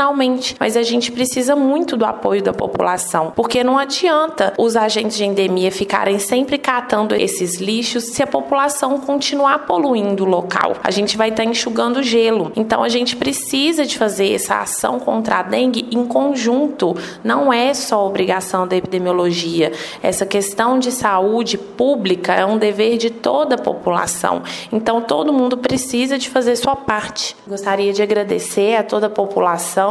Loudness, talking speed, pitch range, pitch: -17 LUFS, 160 wpm, 200-260 Hz, 230 Hz